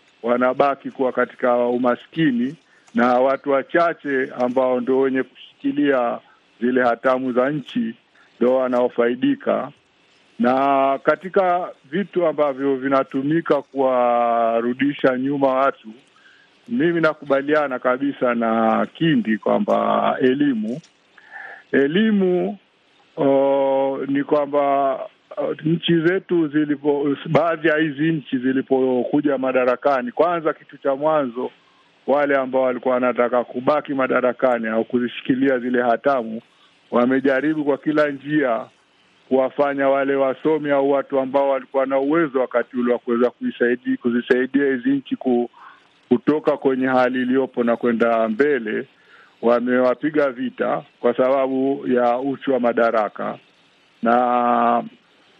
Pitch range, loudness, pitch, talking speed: 125-150 Hz, -20 LUFS, 135 Hz, 105 wpm